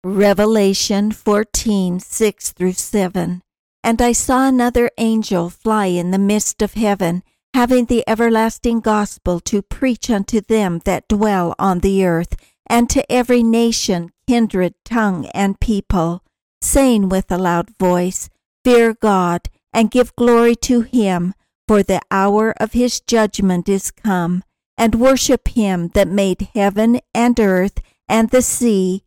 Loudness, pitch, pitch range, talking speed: -16 LUFS, 210 Hz, 190-230 Hz, 140 wpm